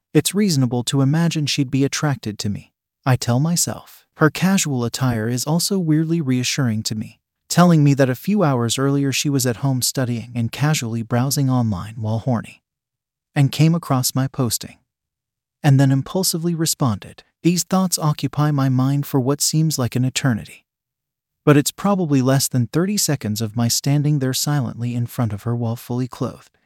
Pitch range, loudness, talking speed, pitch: 120-150 Hz, -19 LUFS, 175 wpm, 135 Hz